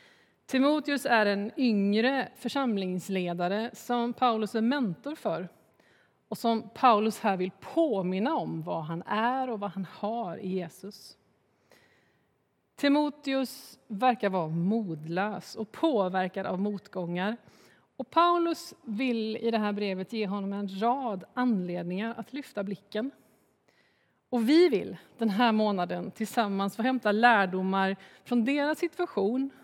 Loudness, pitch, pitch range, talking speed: -29 LUFS, 220 Hz, 195-250 Hz, 125 wpm